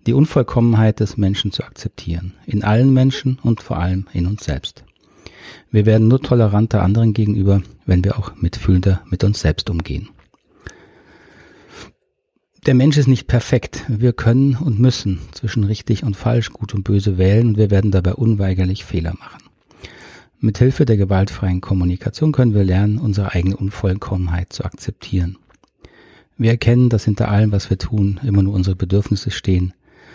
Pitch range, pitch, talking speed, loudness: 95-115 Hz, 105 Hz, 155 wpm, -17 LUFS